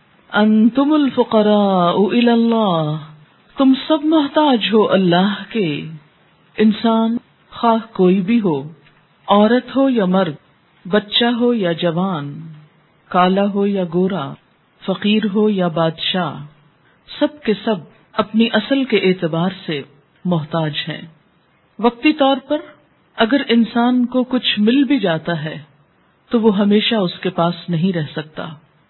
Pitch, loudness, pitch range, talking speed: 200 Hz, -16 LUFS, 165-230 Hz, 125 wpm